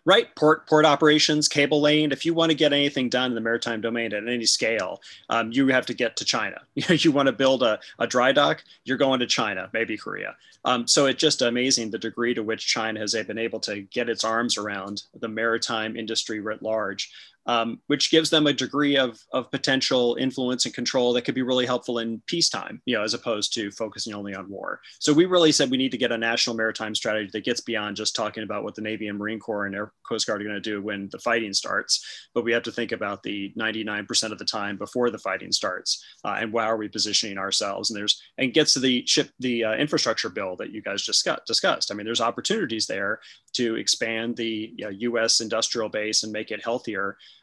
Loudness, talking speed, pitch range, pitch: -24 LUFS, 235 wpm, 110-130 Hz, 115 Hz